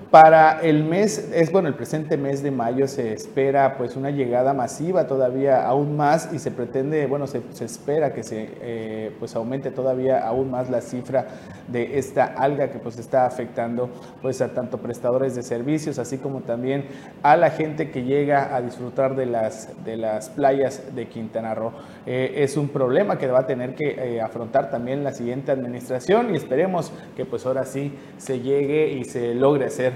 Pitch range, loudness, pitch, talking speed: 120-140 Hz, -22 LUFS, 130 Hz, 190 wpm